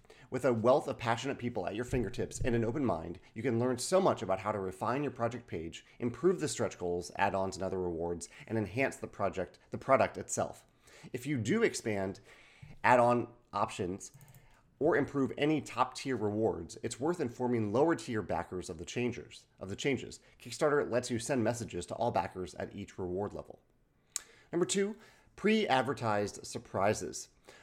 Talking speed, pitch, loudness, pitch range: 165 wpm, 115 Hz, -34 LUFS, 100-135 Hz